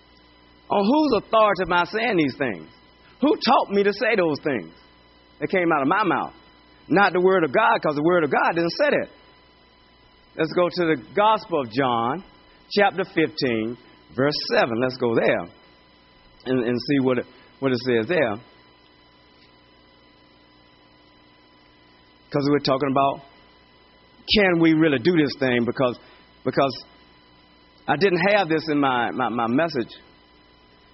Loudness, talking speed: -21 LUFS, 155 wpm